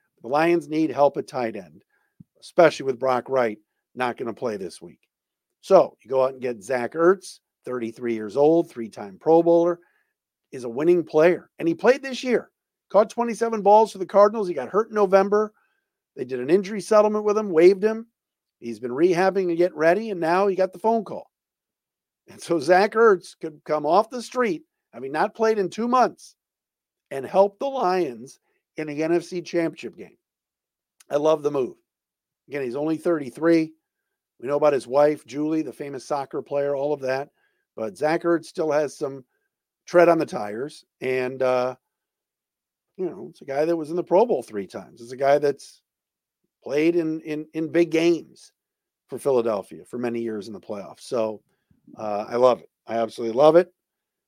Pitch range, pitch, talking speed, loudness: 140-195 Hz, 165 Hz, 190 wpm, -22 LUFS